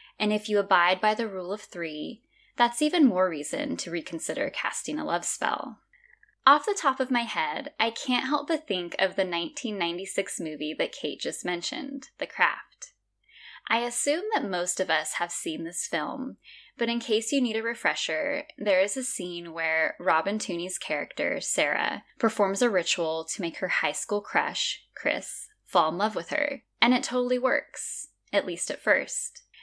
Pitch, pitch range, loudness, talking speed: 225 Hz, 180-275 Hz, -27 LUFS, 180 wpm